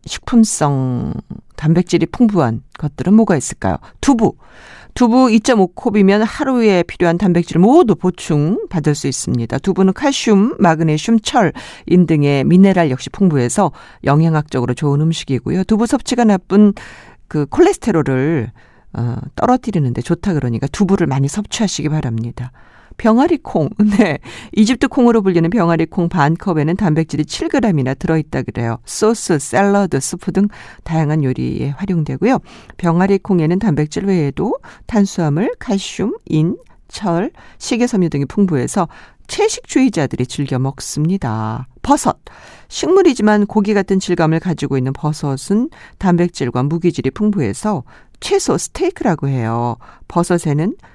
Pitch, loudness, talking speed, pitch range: 170 Hz, -15 LUFS, 315 characters per minute, 140-210 Hz